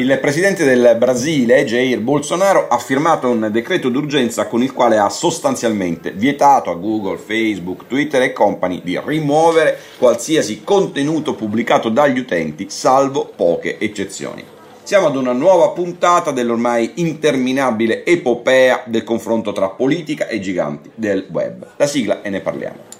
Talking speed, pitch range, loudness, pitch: 140 wpm, 115-160 Hz, -16 LUFS, 125 Hz